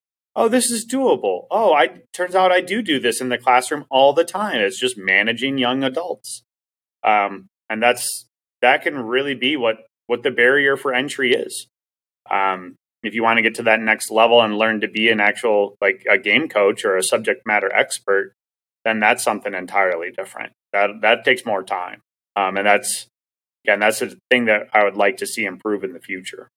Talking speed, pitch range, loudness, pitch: 200 wpm, 100-130 Hz, -18 LUFS, 110 Hz